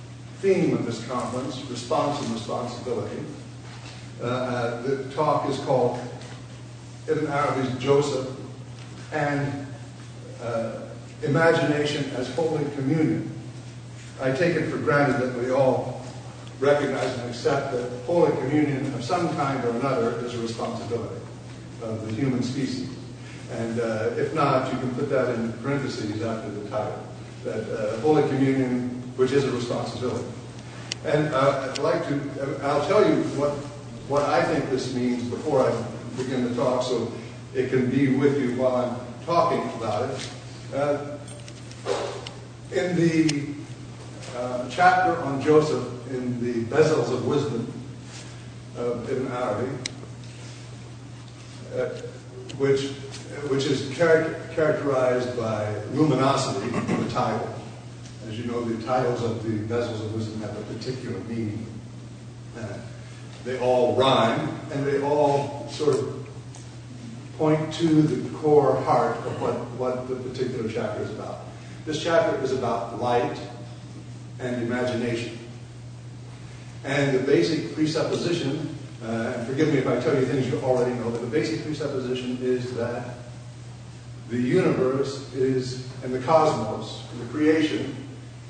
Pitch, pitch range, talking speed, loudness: 125 Hz, 120-140 Hz, 135 wpm, -25 LUFS